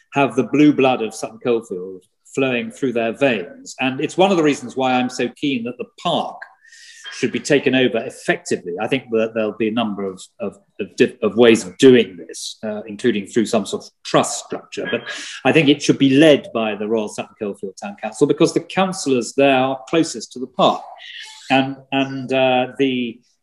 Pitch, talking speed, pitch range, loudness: 130 Hz, 200 wpm, 115-150 Hz, -18 LUFS